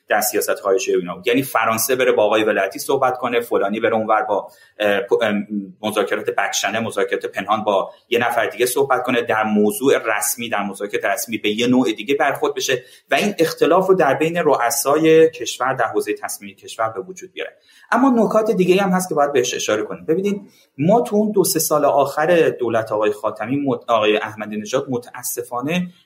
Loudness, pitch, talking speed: -18 LUFS, 155 Hz, 180 wpm